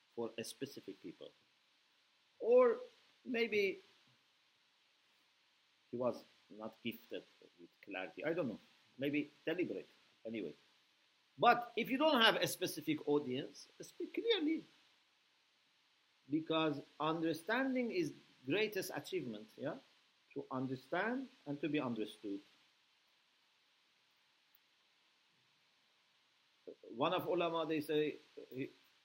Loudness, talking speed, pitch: -38 LUFS, 95 wpm, 170 Hz